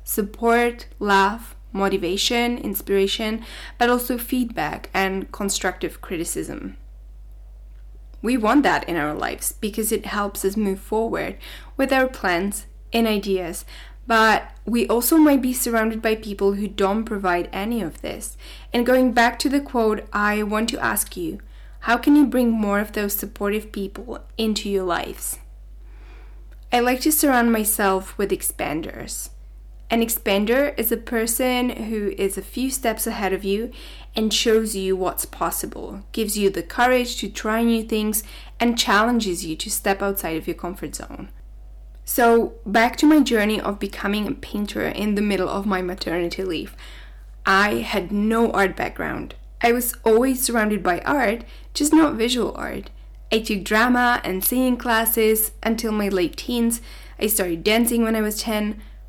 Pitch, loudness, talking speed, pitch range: 215 Hz, -21 LUFS, 155 wpm, 195-235 Hz